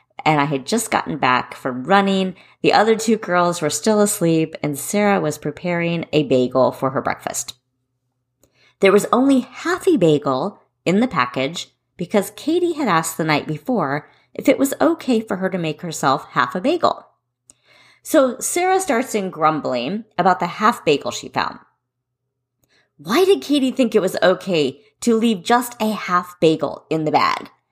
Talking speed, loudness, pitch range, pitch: 170 wpm, -19 LUFS, 140-225 Hz, 180 Hz